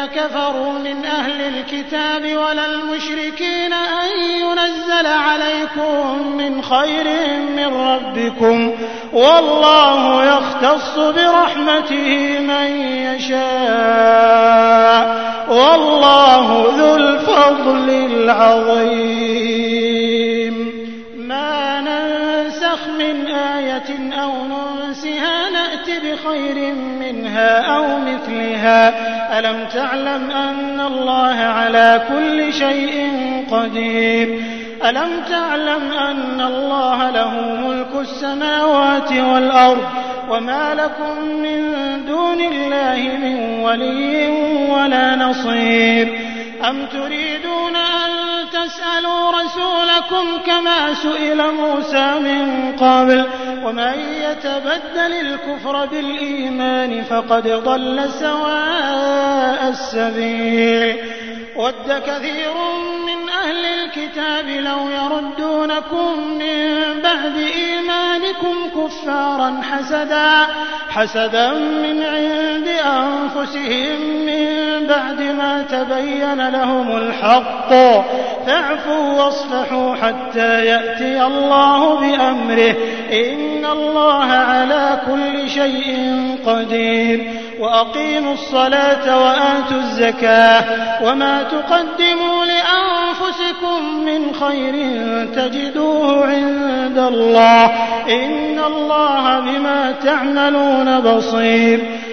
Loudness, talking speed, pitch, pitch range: -15 LUFS, 75 wpm, 280 Hz, 255-305 Hz